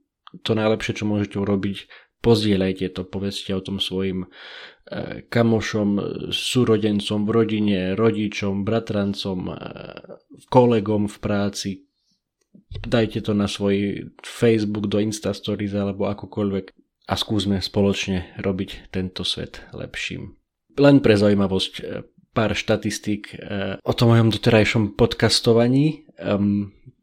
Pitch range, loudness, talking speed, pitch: 100-110 Hz, -22 LUFS, 100 wpm, 105 Hz